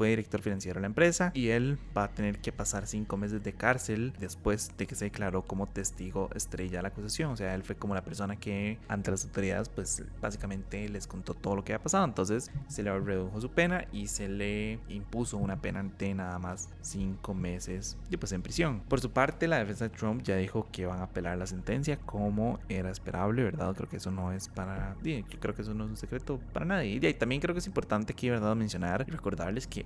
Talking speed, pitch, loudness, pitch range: 235 wpm, 100 Hz, -33 LUFS, 95-115 Hz